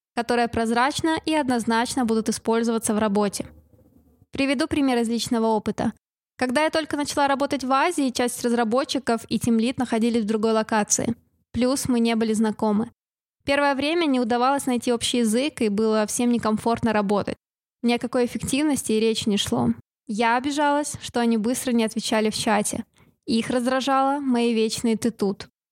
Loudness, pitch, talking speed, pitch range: -23 LUFS, 235 Hz, 155 wpm, 225-265 Hz